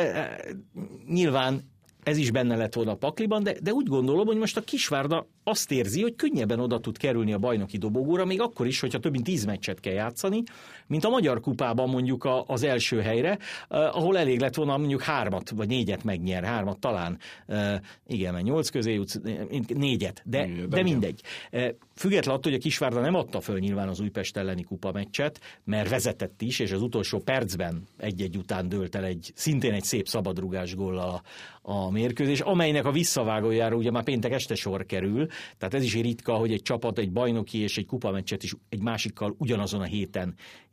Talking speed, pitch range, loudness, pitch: 185 wpm, 100-140 Hz, -28 LUFS, 115 Hz